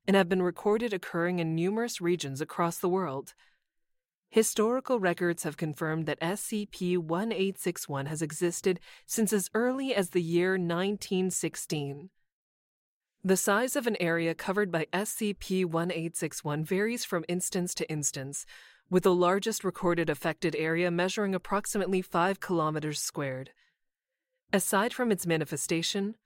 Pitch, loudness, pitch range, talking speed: 180 Hz, -30 LUFS, 165-200 Hz, 130 wpm